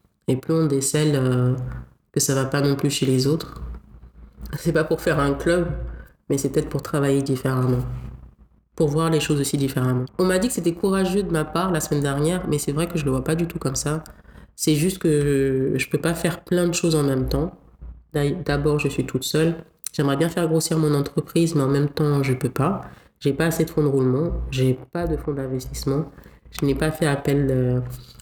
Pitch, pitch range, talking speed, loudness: 145 Hz, 130-160 Hz, 230 wpm, -22 LUFS